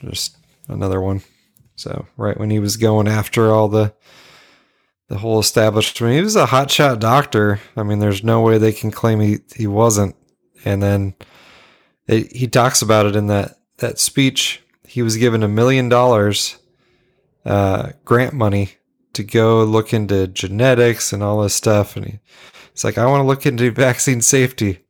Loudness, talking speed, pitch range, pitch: -16 LUFS, 175 wpm, 105-125 Hz, 110 Hz